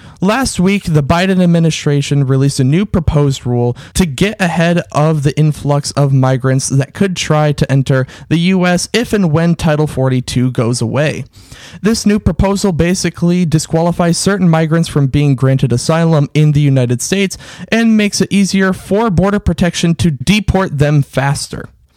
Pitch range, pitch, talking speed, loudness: 140-185 Hz, 160 Hz, 160 wpm, -13 LUFS